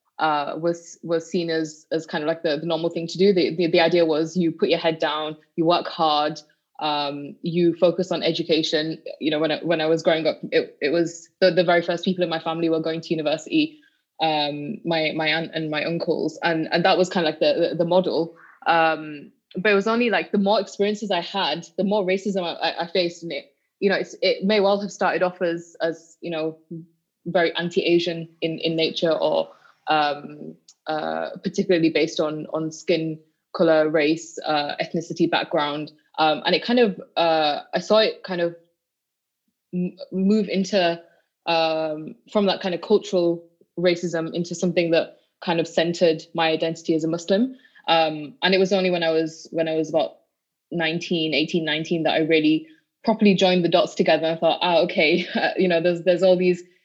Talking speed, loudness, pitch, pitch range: 200 wpm, -22 LUFS, 170 Hz, 160-180 Hz